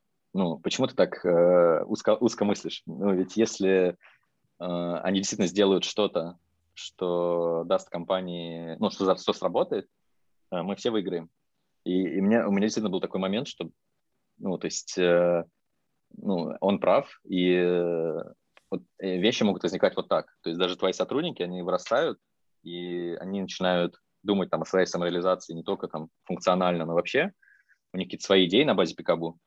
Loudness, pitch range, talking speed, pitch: -27 LUFS, 85-95 Hz, 170 wpm, 90 Hz